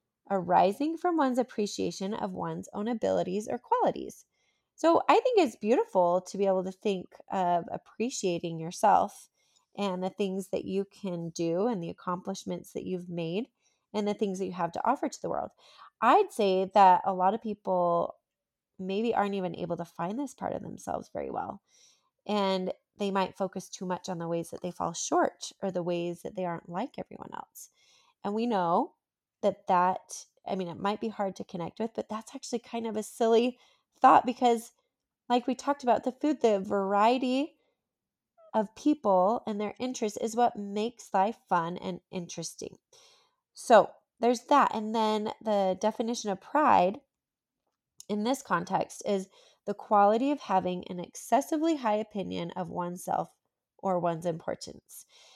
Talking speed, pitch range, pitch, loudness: 170 wpm, 185-240 Hz, 205 Hz, -29 LUFS